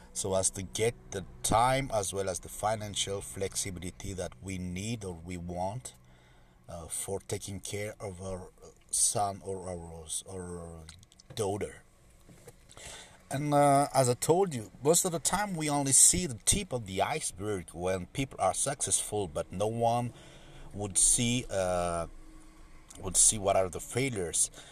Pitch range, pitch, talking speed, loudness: 90-120 Hz, 100 Hz, 155 wpm, -29 LUFS